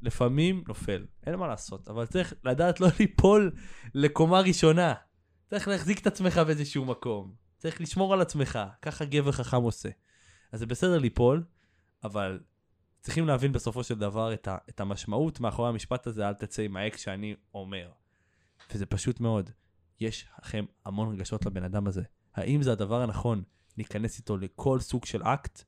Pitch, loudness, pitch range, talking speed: 115 Hz, -29 LUFS, 100-145 Hz, 160 wpm